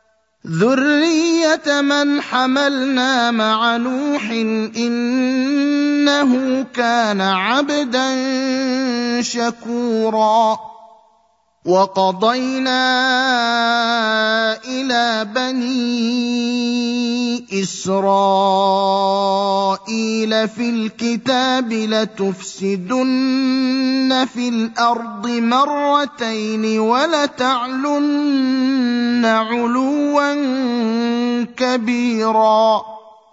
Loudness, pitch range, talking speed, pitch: -17 LUFS, 220-260 Hz, 40 wpm, 240 Hz